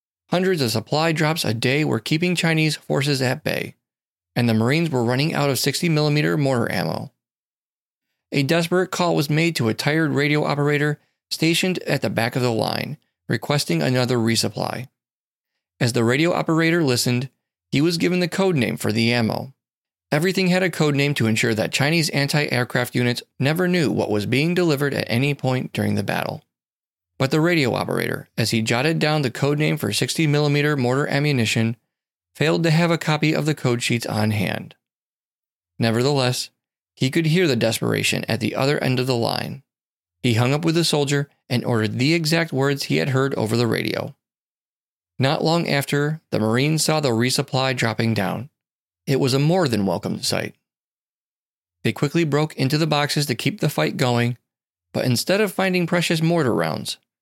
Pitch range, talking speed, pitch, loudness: 120-155 Hz, 180 wpm, 140 Hz, -21 LUFS